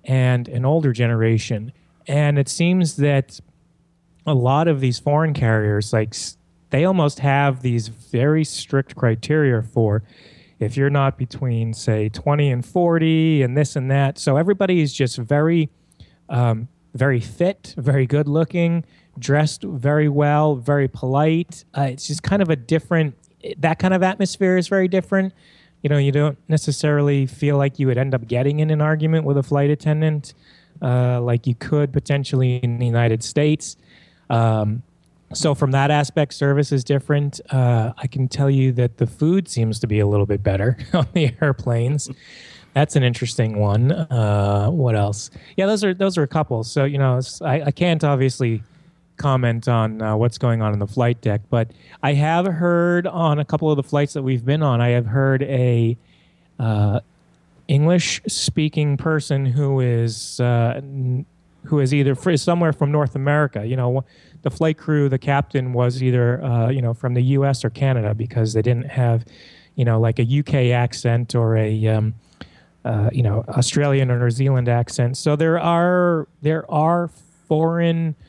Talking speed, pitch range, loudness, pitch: 175 wpm, 120-155 Hz, -19 LUFS, 140 Hz